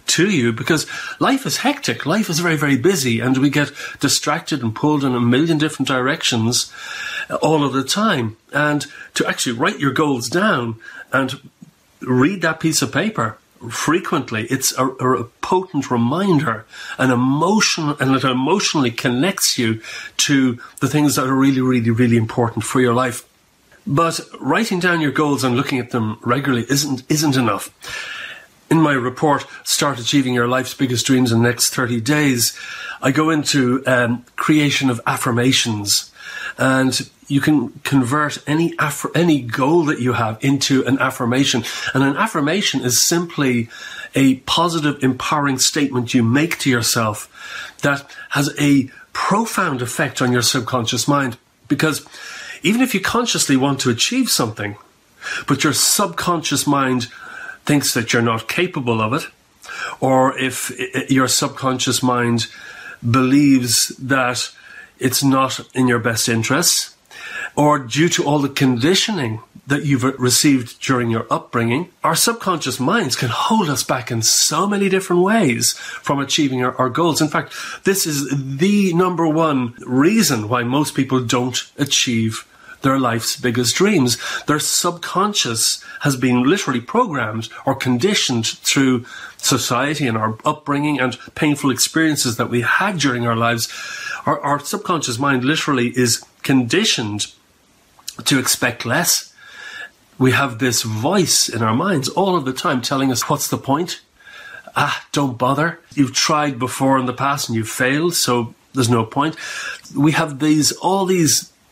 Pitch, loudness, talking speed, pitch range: 135 Hz, -17 LUFS, 150 wpm, 125-150 Hz